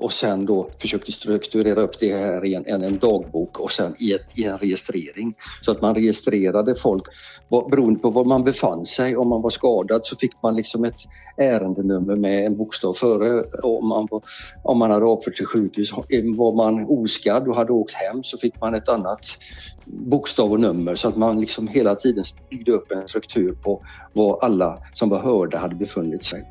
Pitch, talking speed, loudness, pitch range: 110 Hz, 200 wpm, -21 LUFS, 100-115 Hz